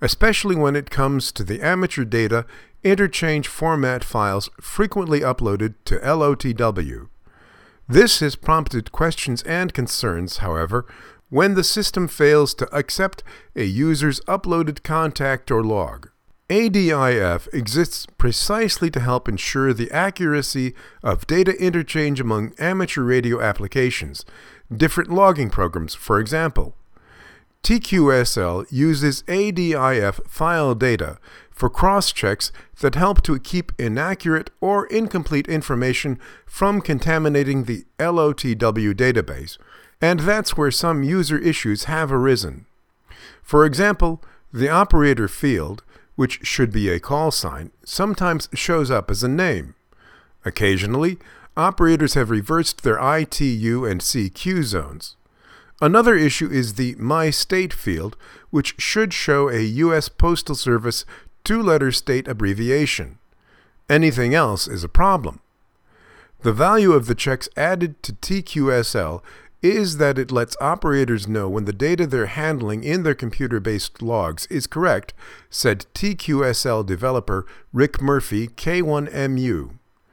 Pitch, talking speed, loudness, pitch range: 140 Hz, 125 wpm, -20 LUFS, 115-165 Hz